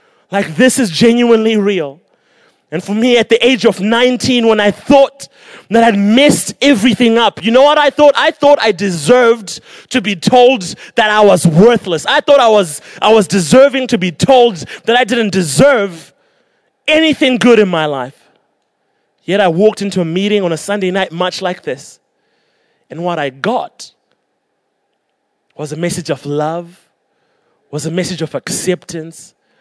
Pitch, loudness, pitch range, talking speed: 215 Hz, -11 LUFS, 180-250 Hz, 170 wpm